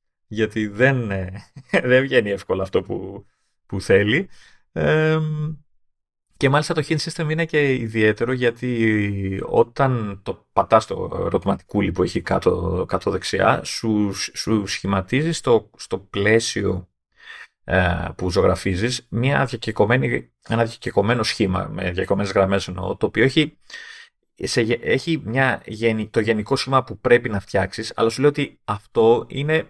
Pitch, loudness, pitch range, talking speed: 115 Hz, -21 LUFS, 100-140 Hz, 135 wpm